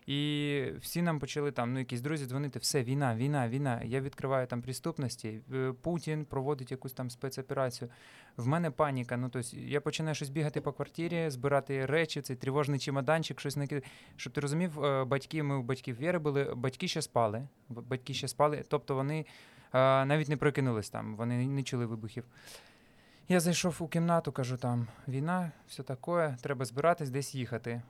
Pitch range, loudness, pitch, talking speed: 130-150 Hz, -33 LUFS, 140 Hz, 170 wpm